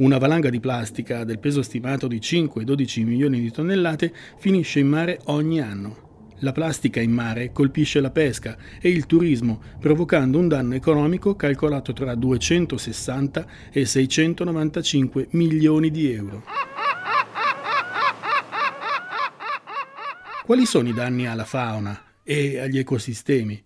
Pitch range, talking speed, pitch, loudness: 120-155 Hz, 120 wpm, 135 Hz, -22 LUFS